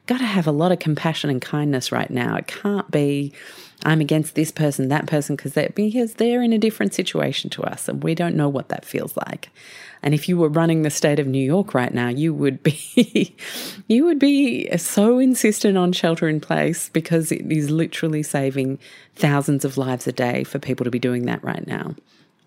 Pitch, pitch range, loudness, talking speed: 155 Hz, 145-185 Hz, -21 LUFS, 215 wpm